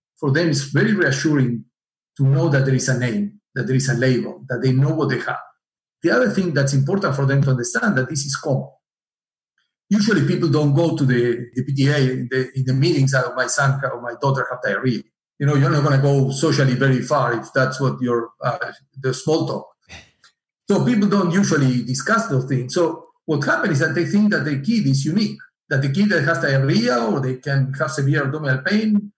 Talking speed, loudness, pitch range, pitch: 220 wpm, -19 LUFS, 130-165 Hz, 140 Hz